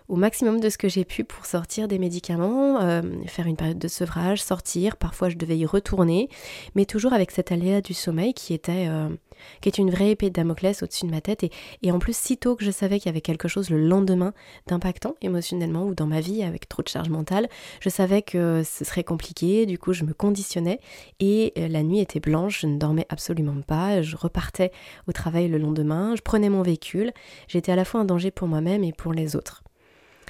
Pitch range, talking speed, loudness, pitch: 165-200 Hz, 225 wpm, -24 LUFS, 180 Hz